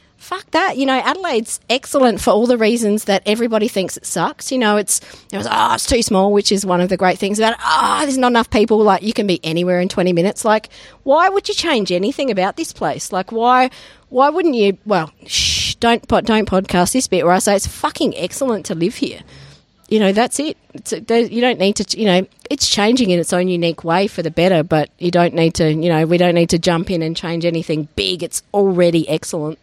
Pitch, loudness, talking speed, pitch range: 200 Hz, -16 LUFS, 235 wpm, 175-235 Hz